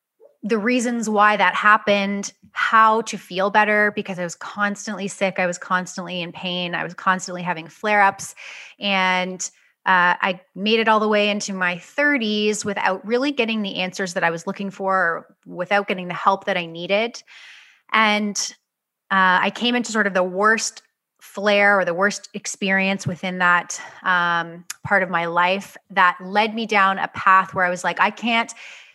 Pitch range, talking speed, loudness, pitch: 180-210 Hz, 180 wpm, -20 LUFS, 195 Hz